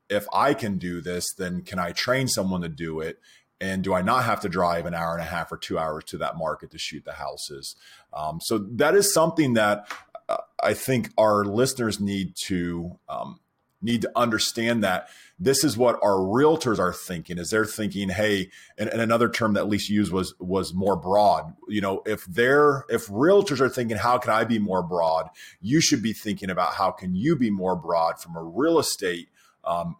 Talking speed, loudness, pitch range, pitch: 210 wpm, -24 LUFS, 90-120 Hz, 105 Hz